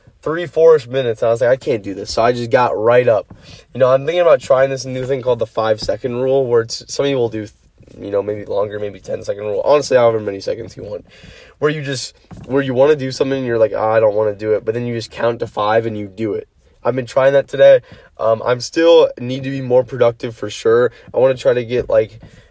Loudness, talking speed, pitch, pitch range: -16 LUFS, 275 wpm, 130 Hz, 115-155 Hz